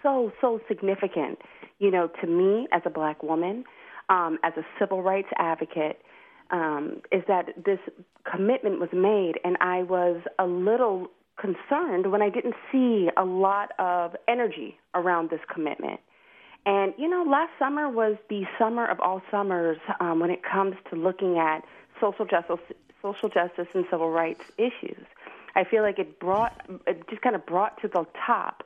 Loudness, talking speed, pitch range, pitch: -26 LUFS, 170 wpm, 175-220 Hz, 190 Hz